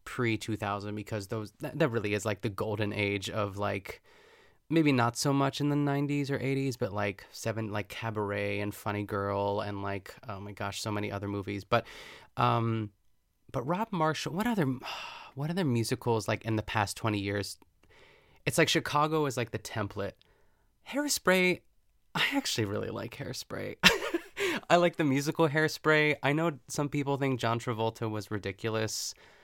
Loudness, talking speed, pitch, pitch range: -31 LUFS, 170 wpm, 115 Hz, 105-150 Hz